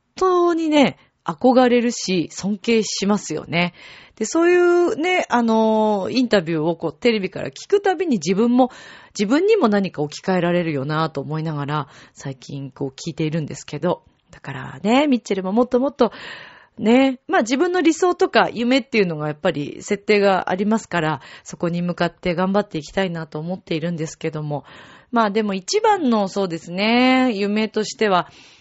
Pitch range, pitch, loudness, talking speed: 165-250 Hz, 205 Hz, -20 LUFS, 365 characters per minute